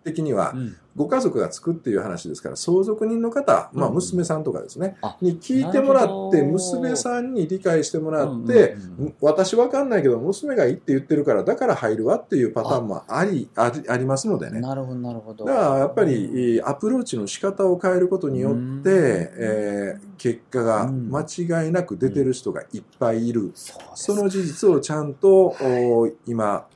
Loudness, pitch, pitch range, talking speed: -22 LUFS, 155 Hz, 125-190 Hz, 355 characters per minute